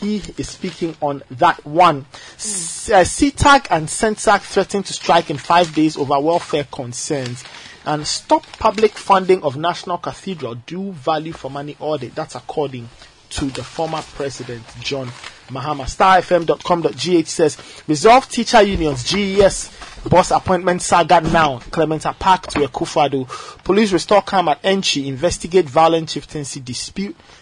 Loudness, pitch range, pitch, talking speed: -17 LUFS, 145-185 Hz, 160 Hz, 140 wpm